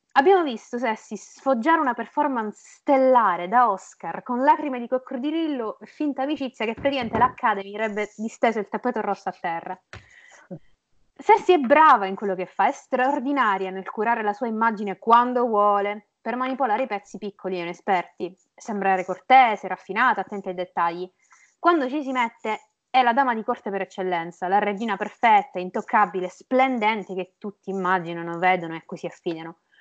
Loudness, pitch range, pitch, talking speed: -23 LUFS, 190-255 Hz, 220 Hz, 155 wpm